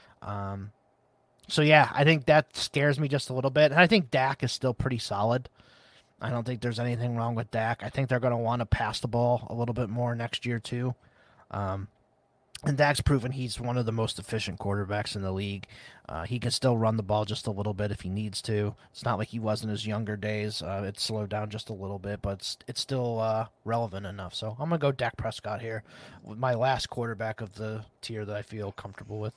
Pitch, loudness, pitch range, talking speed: 115 Hz, -29 LUFS, 105-125 Hz, 240 wpm